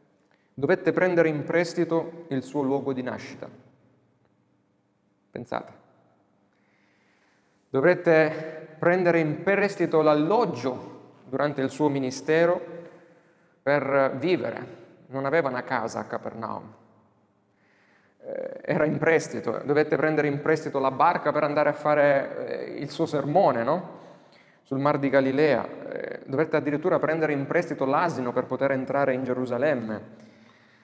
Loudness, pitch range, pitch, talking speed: -25 LUFS, 115-160 Hz, 145 Hz, 115 wpm